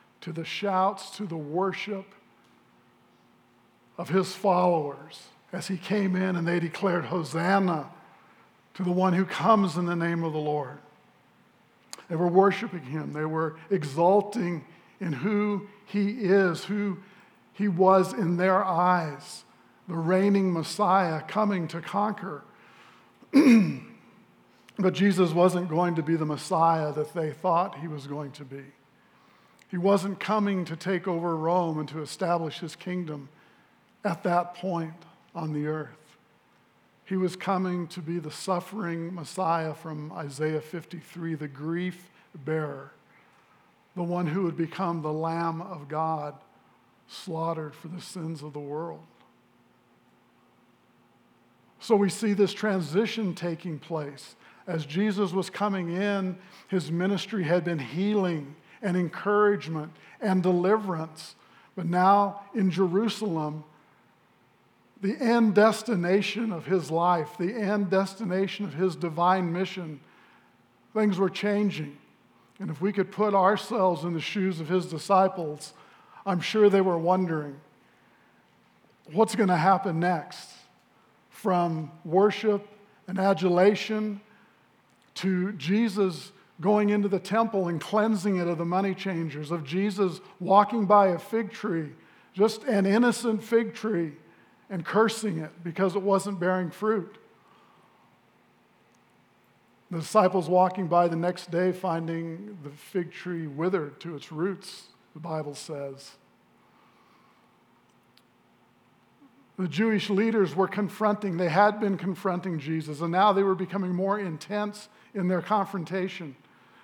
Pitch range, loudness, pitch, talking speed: 165-200 Hz, -27 LUFS, 180 Hz, 130 wpm